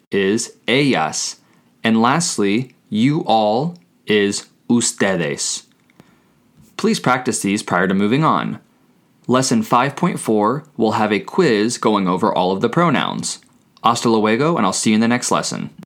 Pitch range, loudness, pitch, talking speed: 105-135 Hz, -17 LUFS, 115 Hz, 140 wpm